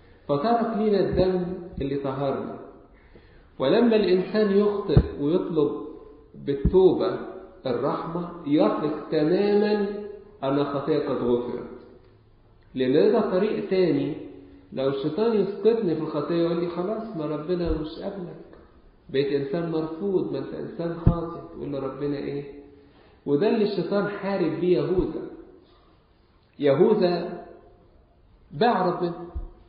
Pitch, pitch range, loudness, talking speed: 175 Hz, 140-205 Hz, -25 LUFS, 105 wpm